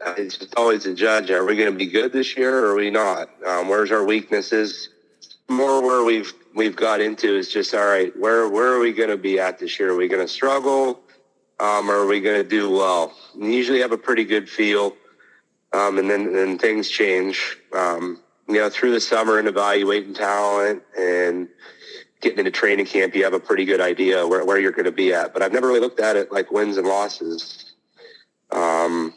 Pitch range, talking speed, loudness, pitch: 100-130 Hz, 220 wpm, -20 LUFS, 110 Hz